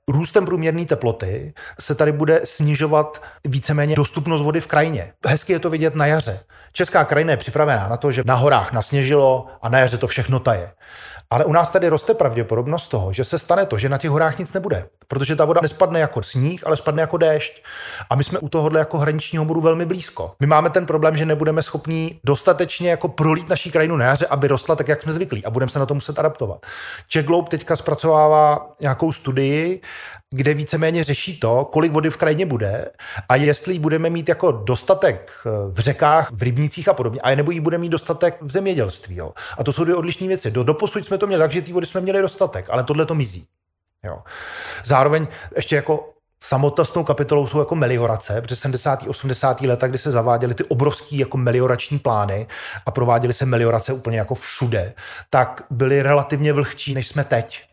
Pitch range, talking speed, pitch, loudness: 130-160 Hz, 200 wpm, 150 Hz, -19 LUFS